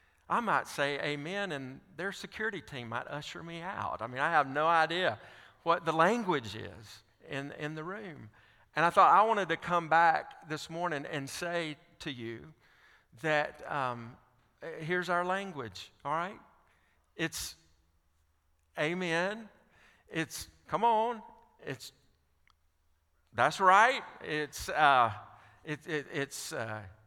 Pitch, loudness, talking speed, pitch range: 145 Hz, -31 LUFS, 135 wpm, 110-170 Hz